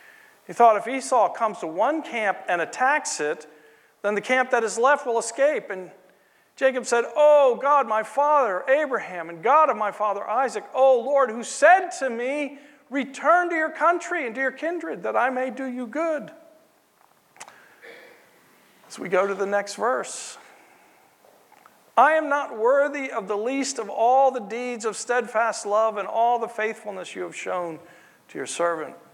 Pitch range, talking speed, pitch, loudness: 210-285 Hz, 175 wpm, 250 Hz, -23 LUFS